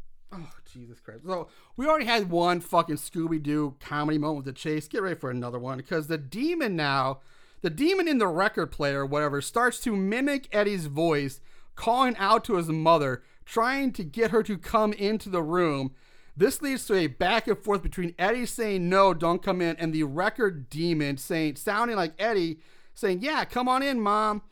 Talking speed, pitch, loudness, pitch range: 190 wpm, 175 Hz, -27 LUFS, 150-220 Hz